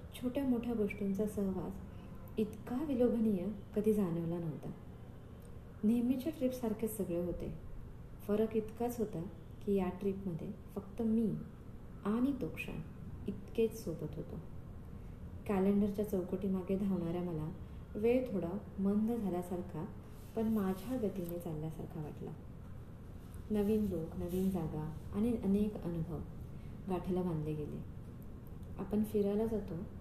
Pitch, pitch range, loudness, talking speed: 200 Hz, 175-220 Hz, -37 LUFS, 105 wpm